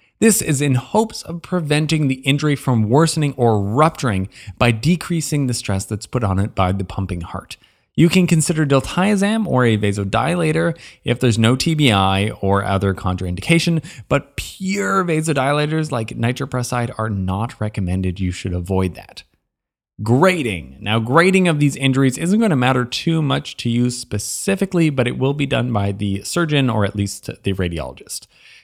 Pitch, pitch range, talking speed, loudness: 125 Hz, 100-155 Hz, 165 wpm, -18 LUFS